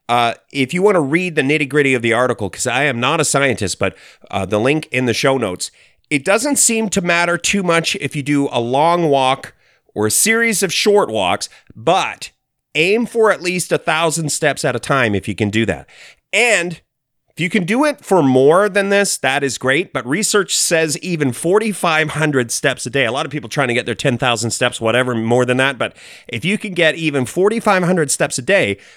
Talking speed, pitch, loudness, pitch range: 220 wpm, 145 Hz, -16 LUFS, 125-180 Hz